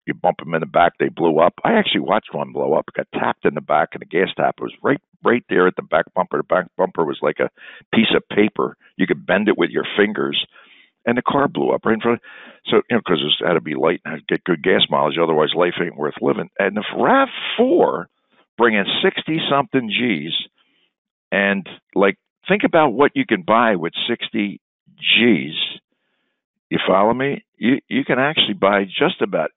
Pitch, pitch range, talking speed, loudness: 105 Hz, 100-140 Hz, 225 wpm, -18 LUFS